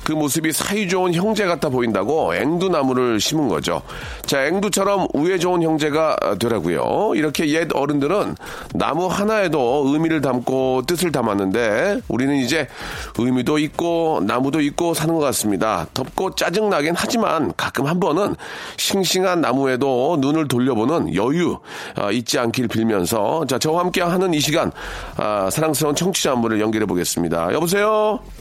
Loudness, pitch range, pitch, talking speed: -19 LUFS, 125-175 Hz, 155 Hz, 335 characters per minute